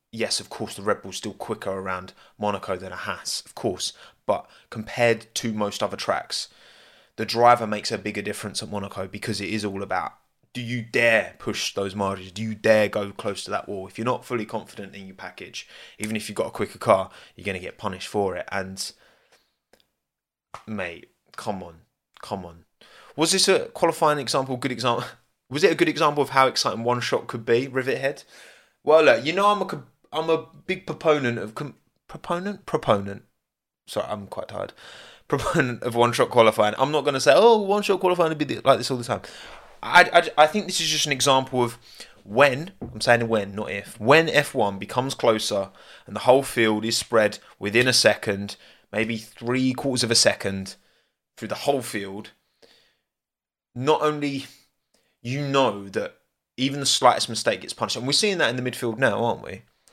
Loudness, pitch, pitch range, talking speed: -23 LUFS, 120 Hz, 105-140 Hz, 195 wpm